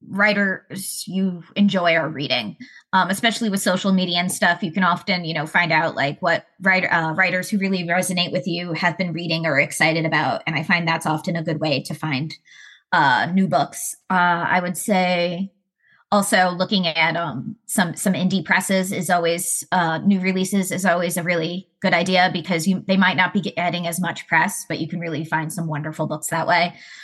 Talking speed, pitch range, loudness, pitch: 200 wpm, 165-190 Hz, -20 LUFS, 180 Hz